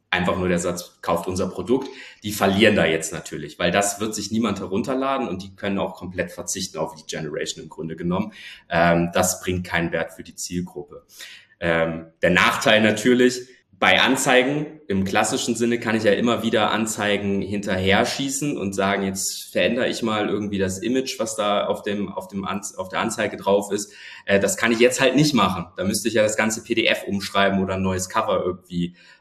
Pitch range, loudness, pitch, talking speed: 90-115 Hz, -22 LUFS, 100 Hz, 200 wpm